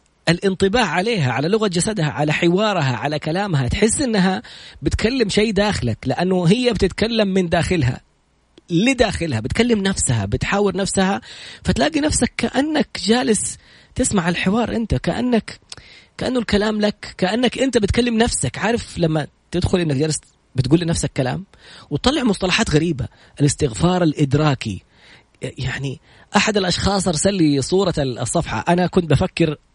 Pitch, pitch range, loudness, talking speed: 180 Hz, 150-215 Hz, -19 LUFS, 125 wpm